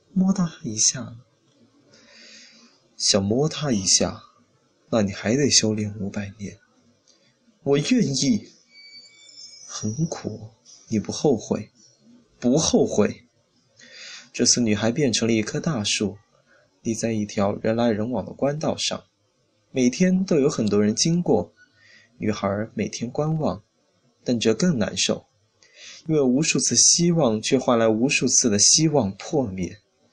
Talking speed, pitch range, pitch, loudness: 180 characters per minute, 105-145 Hz, 115 Hz, -21 LUFS